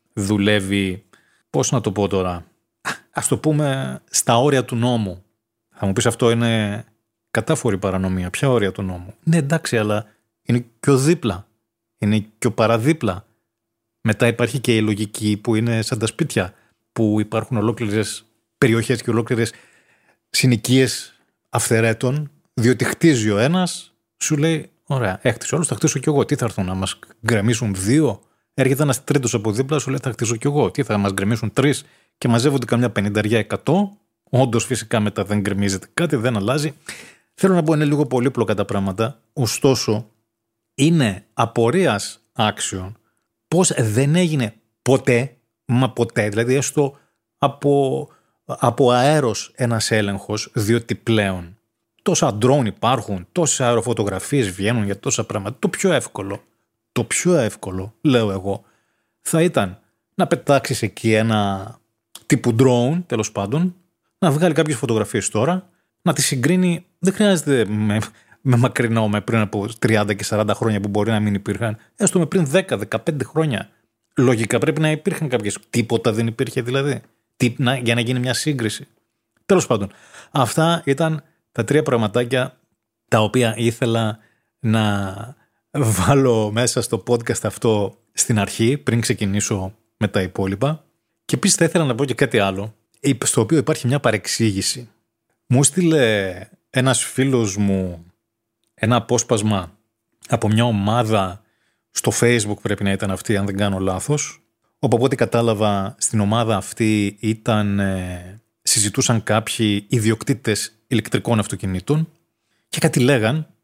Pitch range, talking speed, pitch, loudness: 105-135 Hz, 145 wpm, 115 Hz, -19 LUFS